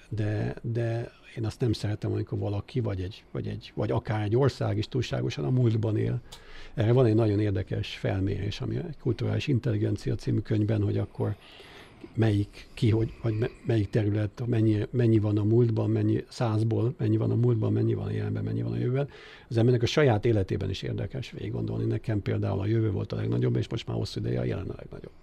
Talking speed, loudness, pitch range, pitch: 200 wpm, -28 LUFS, 105-120 Hz, 110 Hz